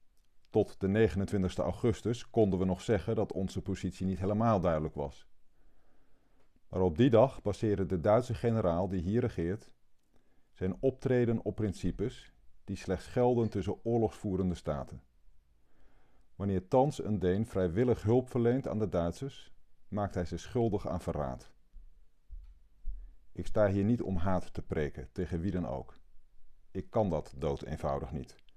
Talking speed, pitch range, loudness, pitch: 145 wpm, 85-110 Hz, -32 LUFS, 95 Hz